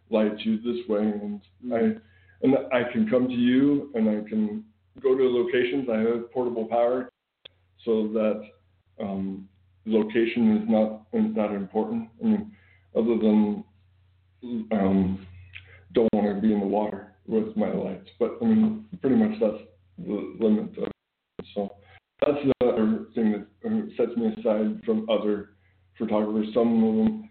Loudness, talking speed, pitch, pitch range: -25 LUFS, 150 wpm, 110 Hz, 100-135 Hz